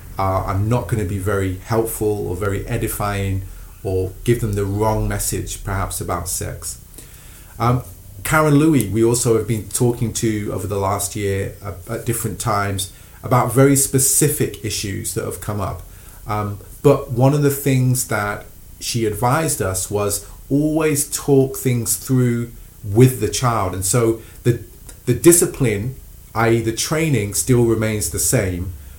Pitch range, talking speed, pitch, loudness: 100-120 Hz, 155 wpm, 110 Hz, -19 LUFS